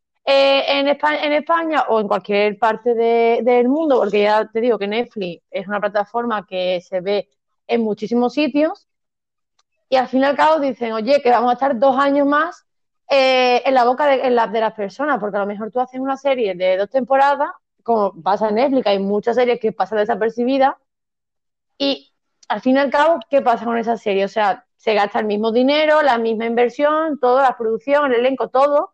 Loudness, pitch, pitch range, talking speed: -17 LUFS, 245 Hz, 215-275 Hz, 210 wpm